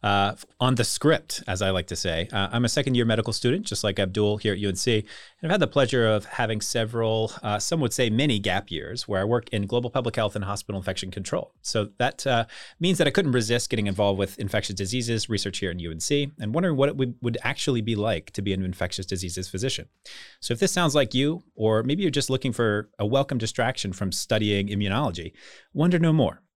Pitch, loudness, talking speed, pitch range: 110 Hz, -25 LUFS, 225 wpm, 100-130 Hz